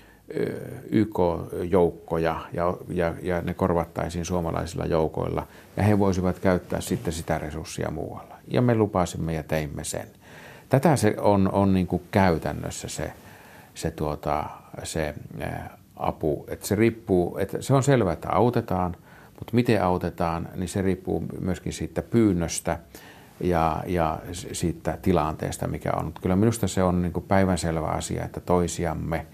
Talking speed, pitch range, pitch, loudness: 140 wpm, 80-100 Hz, 90 Hz, -26 LUFS